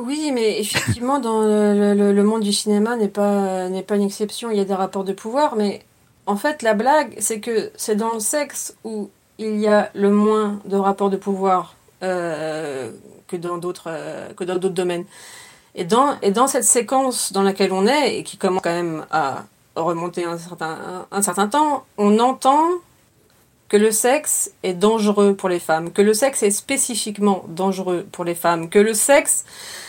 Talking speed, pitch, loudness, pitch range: 195 wpm, 205 Hz, -19 LUFS, 190-225 Hz